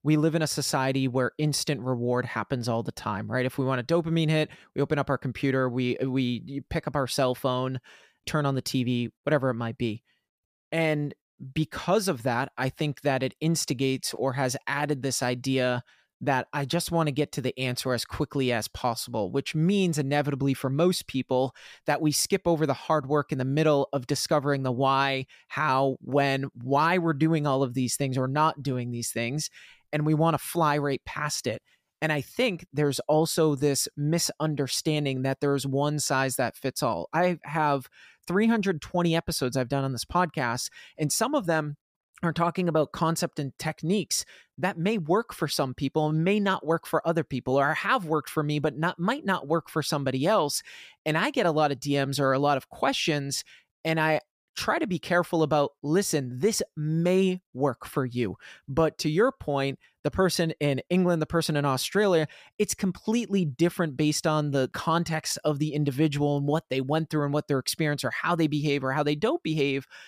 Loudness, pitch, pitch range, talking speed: -27 LUFS, 150 Hz, 135-160 Hz, 200 wpm